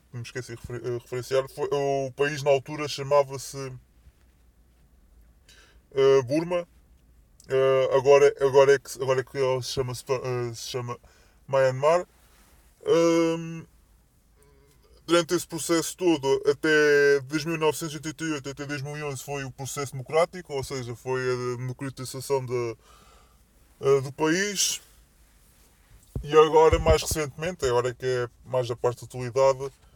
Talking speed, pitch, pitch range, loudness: 130 wpm, 135 Hz, 125-150 Hz, -25 LUFS